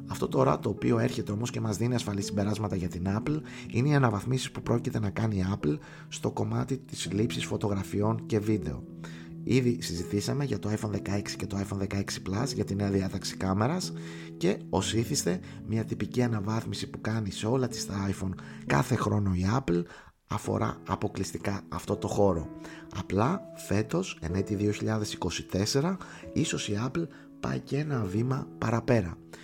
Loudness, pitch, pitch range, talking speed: -30 LUFS, 105 Hz, 95-120 Hz, 165 wpm